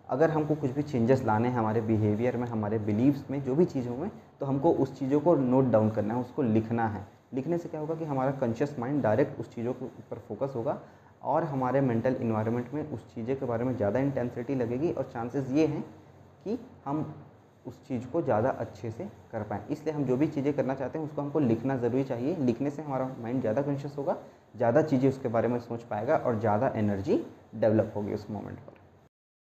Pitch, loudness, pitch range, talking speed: 125 Hz, -29 LUFS, 115-140 Hz, 215 wpm